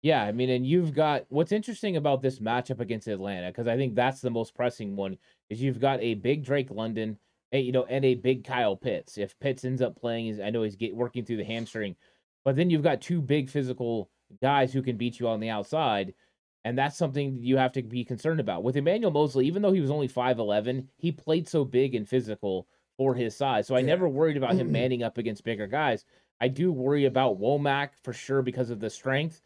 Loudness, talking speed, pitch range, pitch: -28 LUFS, 230 wpm, 115-140 Hz, 130 Hz